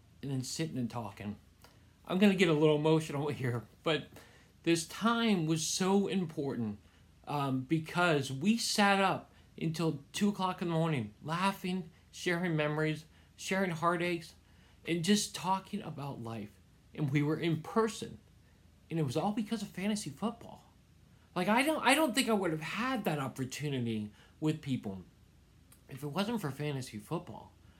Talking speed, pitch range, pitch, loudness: 155 wpm, 125-190 Hz, 155 Hz, -33 LUFS